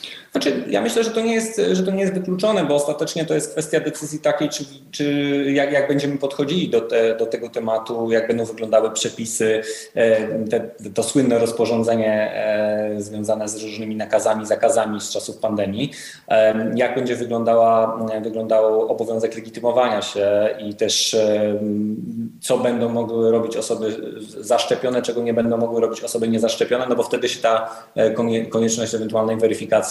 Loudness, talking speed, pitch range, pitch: -20 LUFS, 155 wpm, 110-140 Hz, 115 Hz